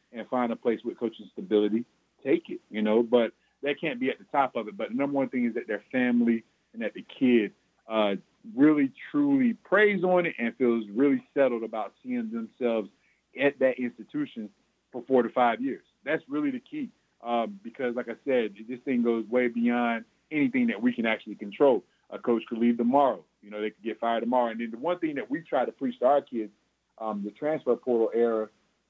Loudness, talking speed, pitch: -28 LUFS, 215 wpm, 125 Hz